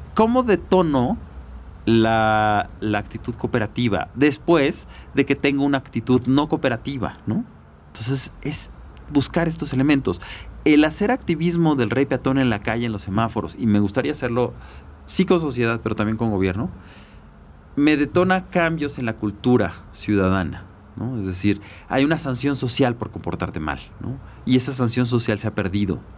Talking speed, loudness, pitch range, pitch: 155 wpm, -21 LUFS, 100-140 Hz, 115 Hz